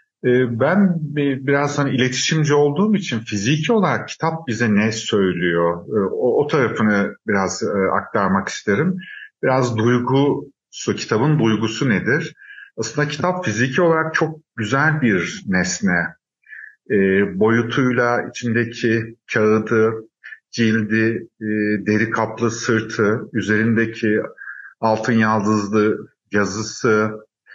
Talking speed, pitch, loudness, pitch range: 90 wpm, 115 Hz, -19 LUFS, 110-140 Hz